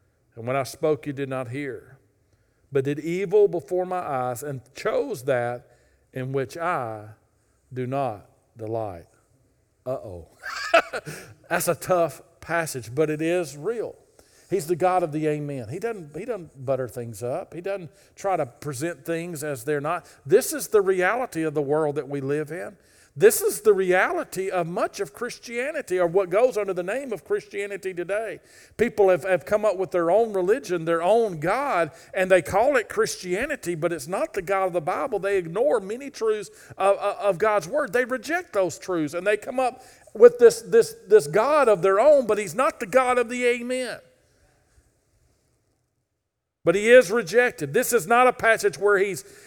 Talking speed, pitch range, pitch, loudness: 180 wpm, 150-240 Hz, 185 Hz, -23 LUFS